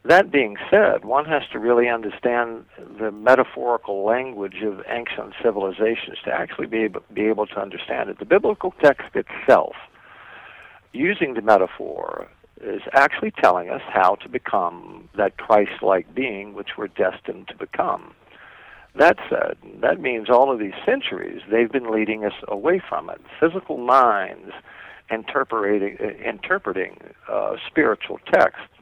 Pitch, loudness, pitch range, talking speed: 110 Hz, -21 LUFS, 105-120 Hz, 135 wpm